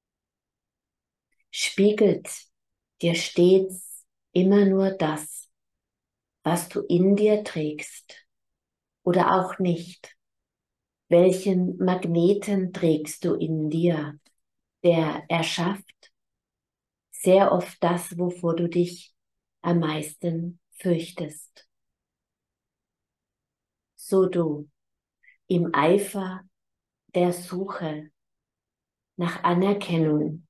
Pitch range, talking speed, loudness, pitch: 160-185 Hz, 75 wpm, -24 LUFS, 175 Hz